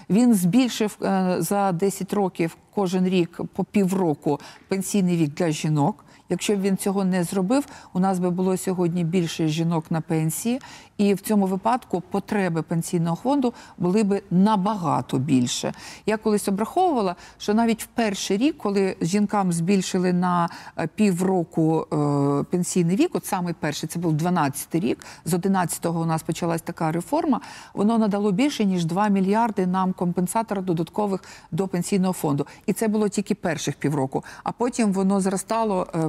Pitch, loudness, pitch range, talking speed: 190 Hz, -23 LUFS, 170-210 Hz, 150 wpm